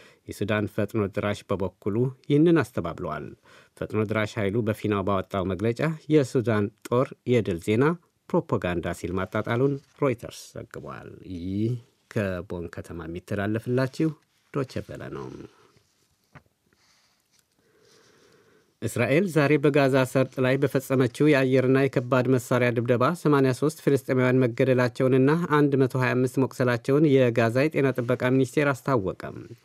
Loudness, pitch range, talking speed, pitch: -24 LUFS, 105-135 Hz, 95 wpm, 125 Hz